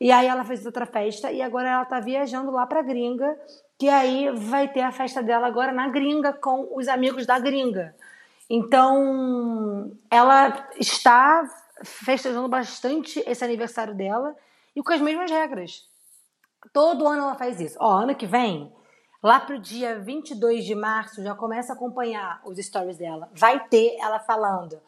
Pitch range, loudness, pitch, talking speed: 230-275 Hz, -22 LUFS, 255 Hz, 165 wpm